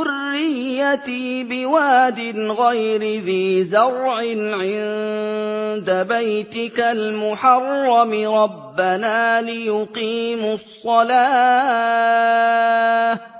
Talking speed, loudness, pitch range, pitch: 50 wpm, -18 LUFS, 215-250 Hz, 230 Hz